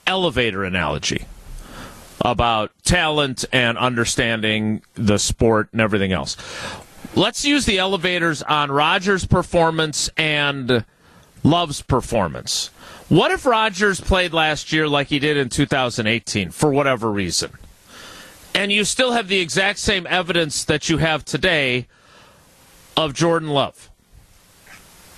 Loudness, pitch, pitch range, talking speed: -19 LUFS, 150 Hz, 120-175 Hz, 120 wpm